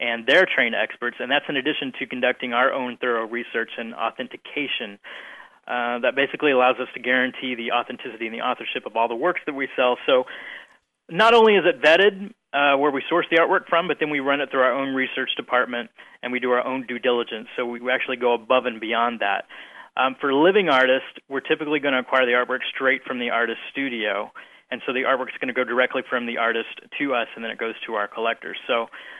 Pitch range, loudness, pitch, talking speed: 120-140 Hz, -22 LUFS, 130 Hz, 230 wpm